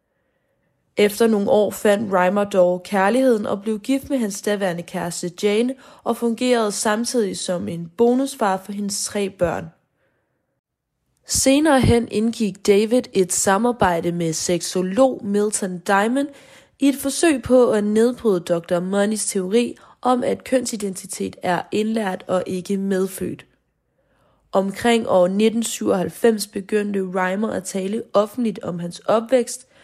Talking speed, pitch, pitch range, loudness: 125 wpm, 205 Hz, 185-235 Hz, -20 LUFS